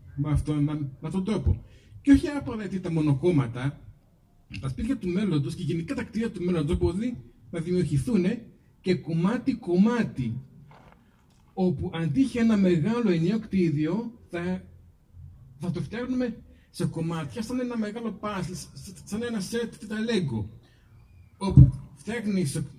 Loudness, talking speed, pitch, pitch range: -27 LUFS, 130 wpm, 175 Hz, 140-215 Hz